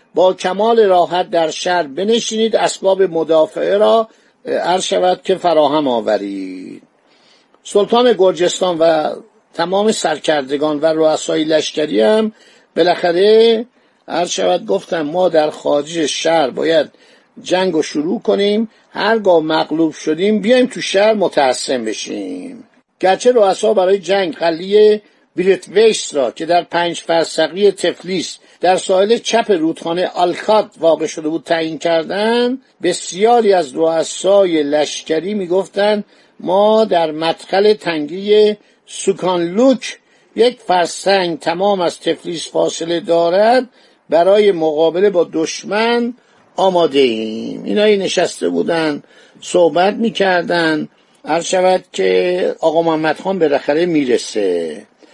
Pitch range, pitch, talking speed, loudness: 160-210 Hz, 180 Hz, 110 wpm, -15 LUFS